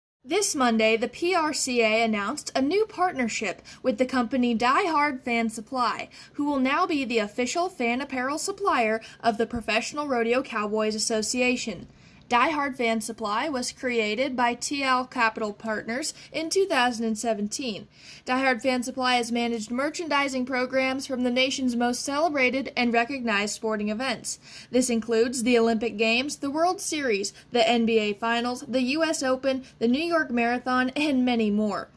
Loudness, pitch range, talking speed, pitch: -25 LUFS, 230-275 Hz, 150 wpm, 250 Hz